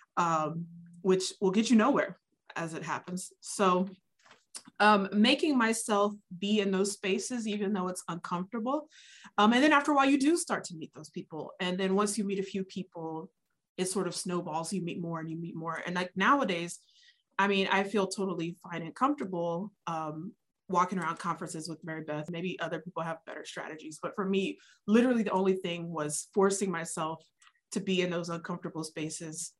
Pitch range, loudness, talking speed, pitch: 170-205 Hz, -31 LUFS, 190 wpm, 185 Hz